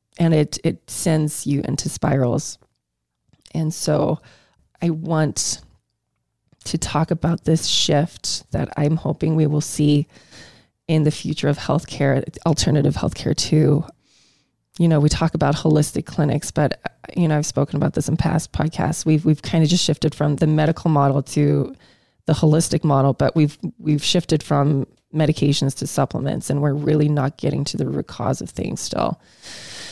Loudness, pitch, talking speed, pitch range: -20 LUFS, 150 Hz, 160 wpm, 145-160 Hz